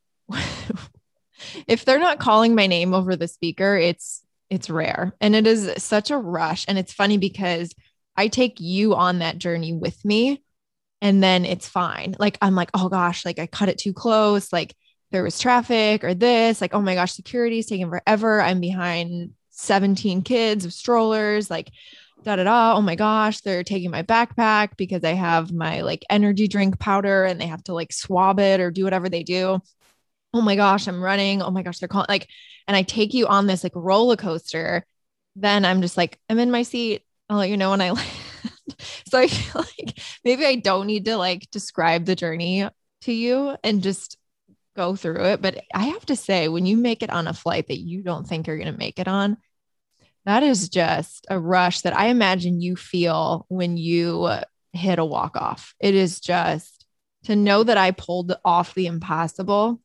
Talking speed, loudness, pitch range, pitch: 195 wpm, -21 LUFS, 175-210 Hz, 190 Hz